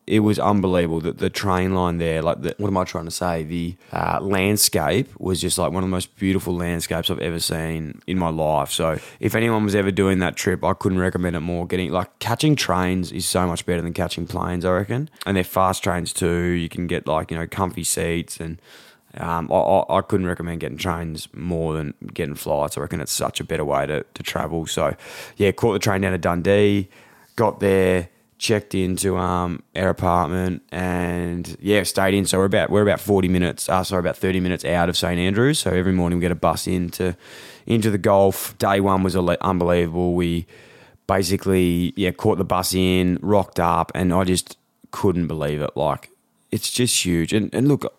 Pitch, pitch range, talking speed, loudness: 90 Hz, 85-95 Hz, 215 wpm, -21 LUFS